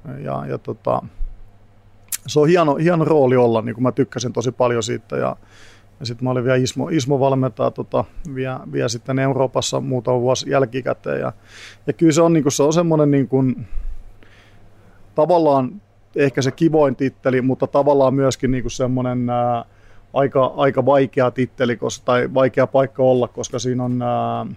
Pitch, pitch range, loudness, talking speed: 125 Hz, 115-135 Hz, -19 LUFS, 165 wpm